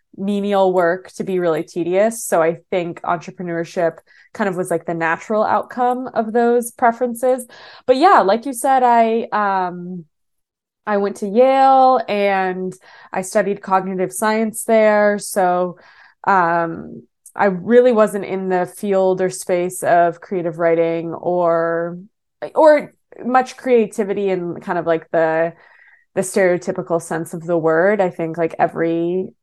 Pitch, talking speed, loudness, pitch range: 190 Hz, 140 wpm, -17 LUFS, 175-225 Hz